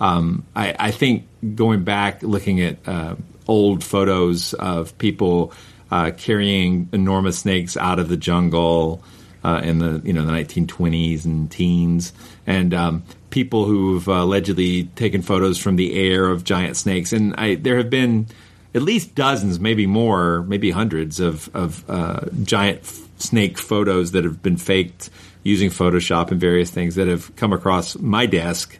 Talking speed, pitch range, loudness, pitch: 160 wpm, 85-100 Hz, -19 LUFS, 90 Hz